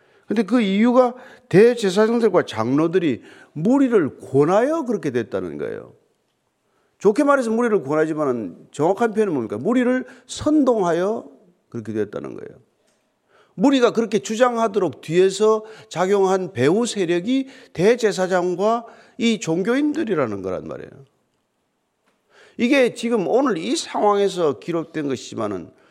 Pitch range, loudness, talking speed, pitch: 180-250 Hz, -20 LUFS, 300 characters per minute, 220 Hz